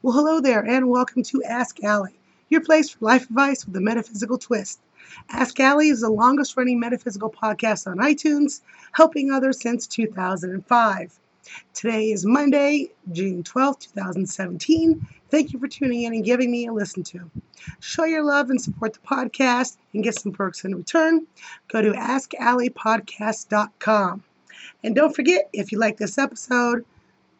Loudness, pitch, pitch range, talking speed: -21 LUFS, 240 Hz, 210-275 Hz, 160 wpm